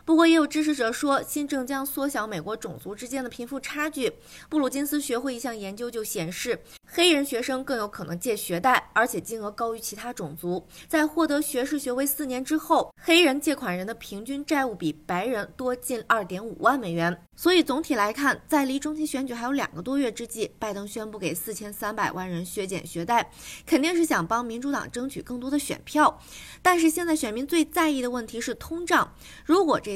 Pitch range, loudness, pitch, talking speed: 220-295 Hz, -26 LUFS, 255 Hz, 315 characters per minute